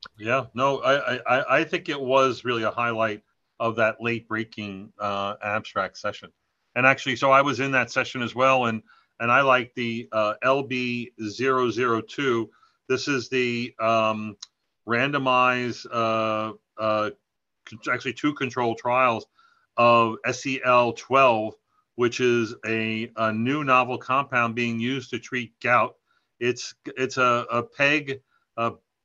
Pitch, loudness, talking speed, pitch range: 120 Hz, -24 LUFS, 140 wpm, 110-130 Hz